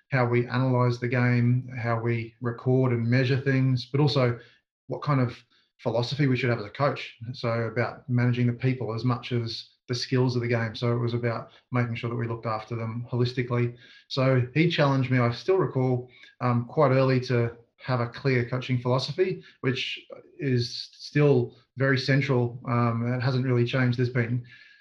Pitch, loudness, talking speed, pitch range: 125 Hz, -26 LUFS, 185 wpm, 120-130 Hz